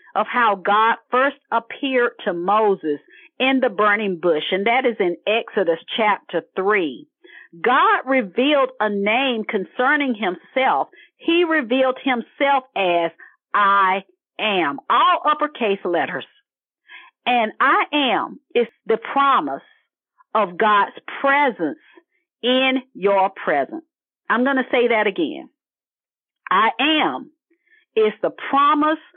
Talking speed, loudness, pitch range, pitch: 115 wpm, -19 LUFS, 210-305 Hz, 260 Hz